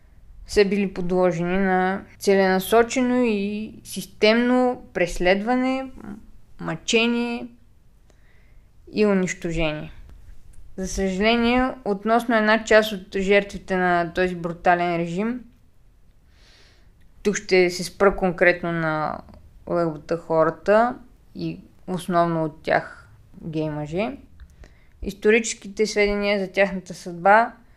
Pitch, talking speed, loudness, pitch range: 190 Hz, 85 wpm, -22 LUFS, 170-215 Hz